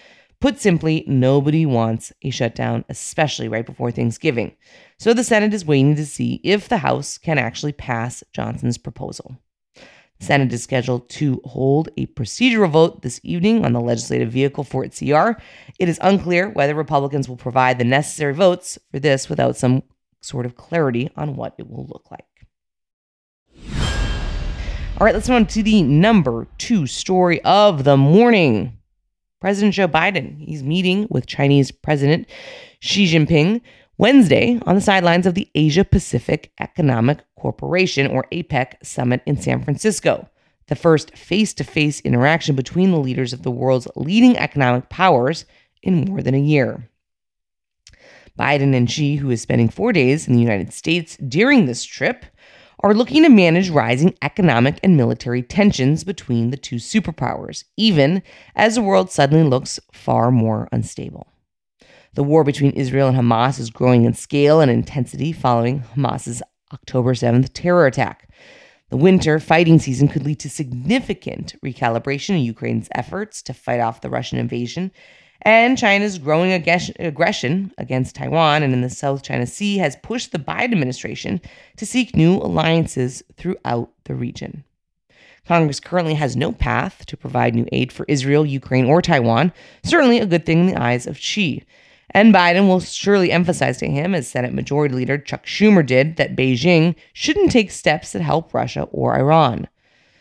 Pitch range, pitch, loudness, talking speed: 125-185 Hz, 145 Hz, -17 LUFS, 160 wpm